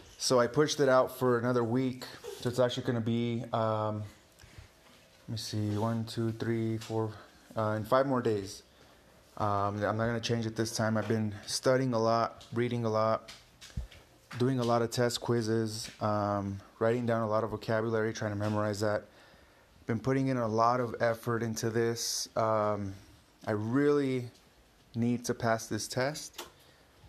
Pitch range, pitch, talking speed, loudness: 105-120 Hz, 115 Hz, 175 wpm, -31 LUFS